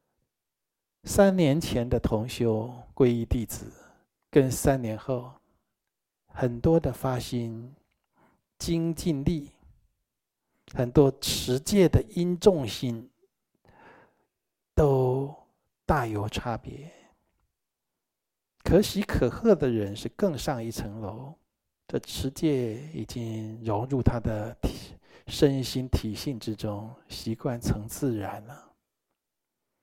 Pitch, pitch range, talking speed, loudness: 125 Hz, 115-145 Hz, 135 characters per minute, -27 LUFS